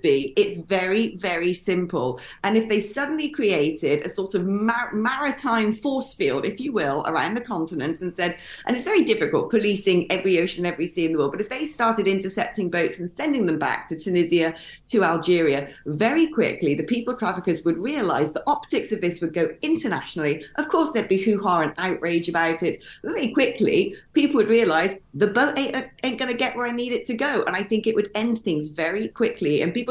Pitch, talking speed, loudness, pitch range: 210 Hz, 205 wpm, -23 LUFS, 175-255 Hz